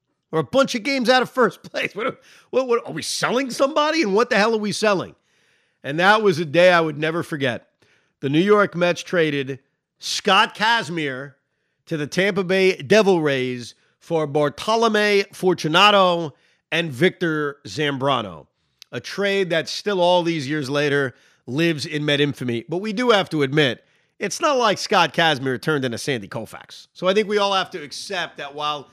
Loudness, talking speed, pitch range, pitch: -20 LUFS, 185 wpm, 145-200 Hz, 165 Hz